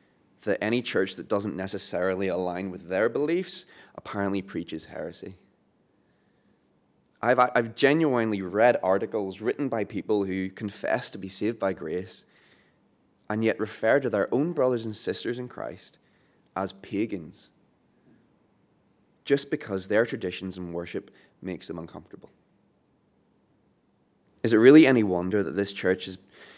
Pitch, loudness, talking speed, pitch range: 105 Hz, -26 LUFS, 135 wpm, 95-120 Hz